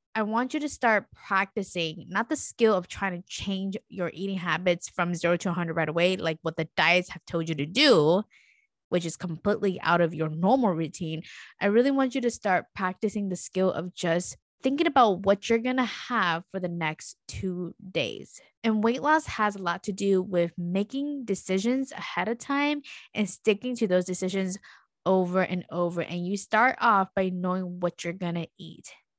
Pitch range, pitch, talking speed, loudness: 175-220 Hz, 190 Hz, 195 wpm, -27 LUFS